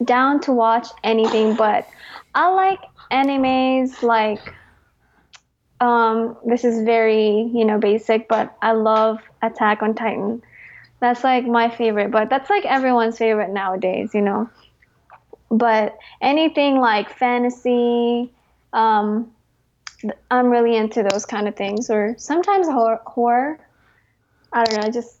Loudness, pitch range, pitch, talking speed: -19 LUFS, 220-250 Hz, 230 Hz, 130 wpm